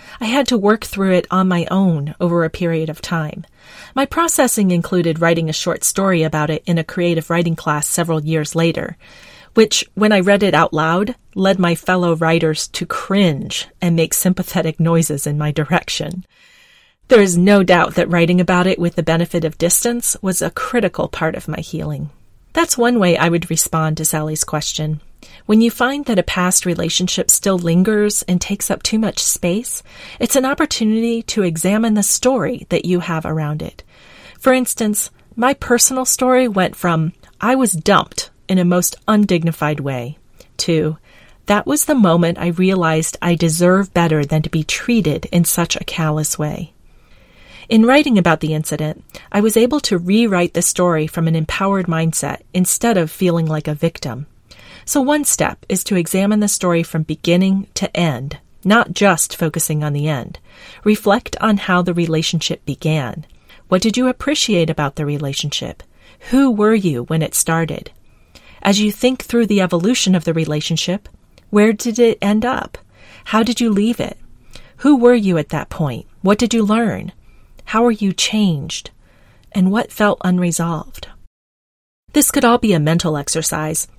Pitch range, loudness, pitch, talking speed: 160-215 Hz, -16 LUFS, 180 Hz, 175 wpm